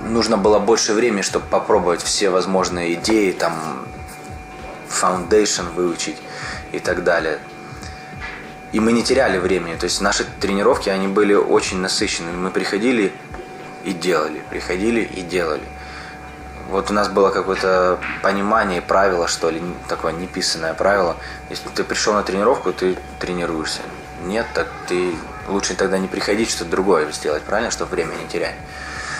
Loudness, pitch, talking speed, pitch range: -19 LUFS, 95 Hz, 140 wpm, 85-105 Hz